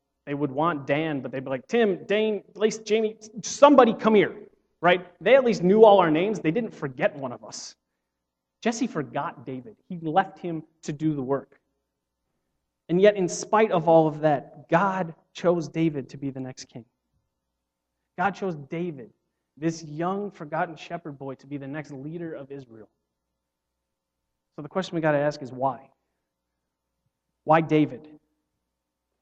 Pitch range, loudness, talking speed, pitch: 125-180 Hz, -24 LUFS, 165 wpm, 150 Hz